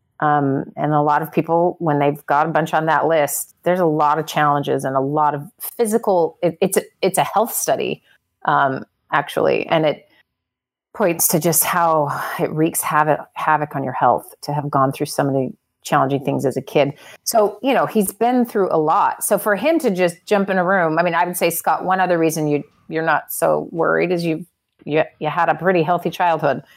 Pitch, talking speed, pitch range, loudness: 160 Hz, 215 wpm, 145-180 Hz, -18 LUFS